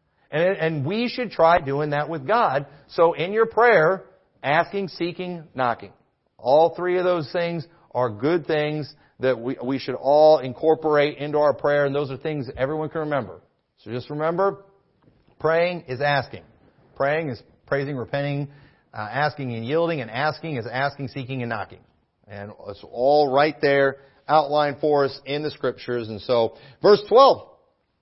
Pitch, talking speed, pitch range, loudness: 145 Hz, 165 wpm, 135-160 Hz, -22 LUFS